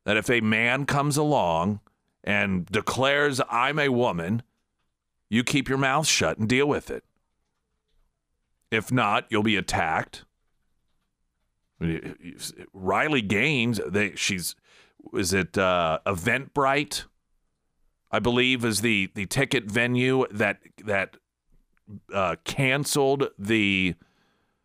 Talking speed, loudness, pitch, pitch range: 110 wpm, -24 LUFS, 115 Hz, 95-135 Hz